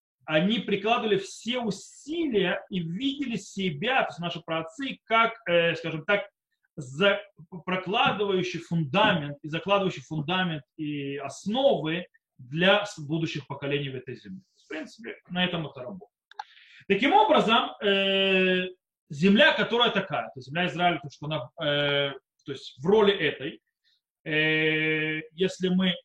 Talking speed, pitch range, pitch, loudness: 130 wpm, 155-205 Hz, 185 Hz, -26 LUFS